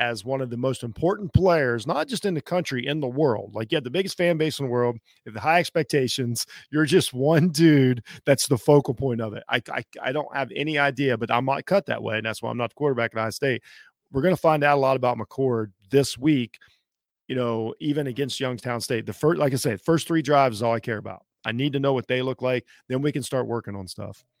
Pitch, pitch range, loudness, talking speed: 135 Hz, 120-150 Hz, -24 LUFS, 260 wpm